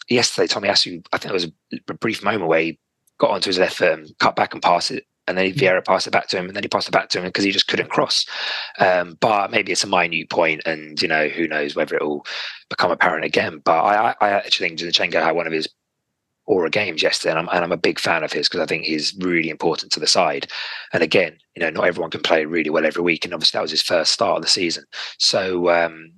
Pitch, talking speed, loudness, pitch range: 85 Hz, 270 wpm, -19 LUFS, 80-90 Hz